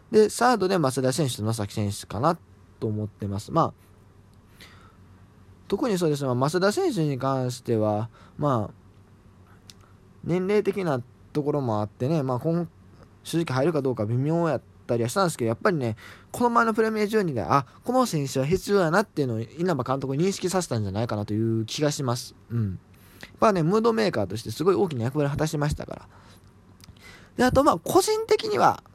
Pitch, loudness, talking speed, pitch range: 125 Hz, -25 LUFS, 370 characters per minute, 100-165 Hz